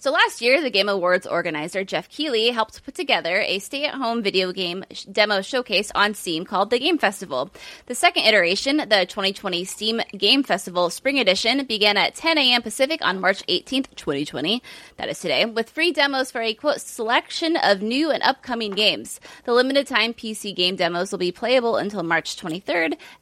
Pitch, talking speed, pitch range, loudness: 220 Hz, 190 wpm, 190-270 Hz, -21 LUFS